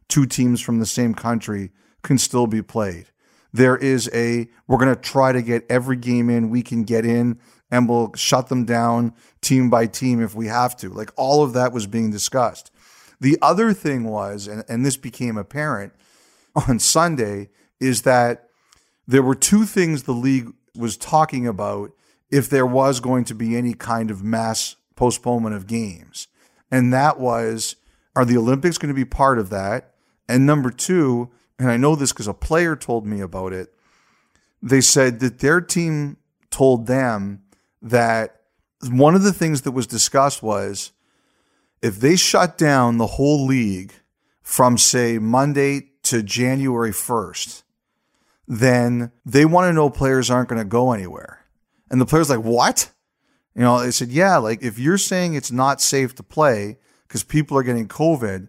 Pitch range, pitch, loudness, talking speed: 115-135 Hz, 125 Hz, -19 LUFS, 175 wpm